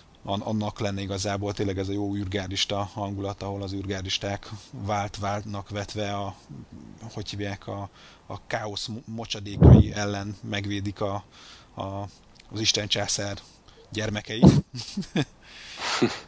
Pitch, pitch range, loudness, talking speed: 100 Hz, 100-110 Hz, -26 LUFS, 105 wpm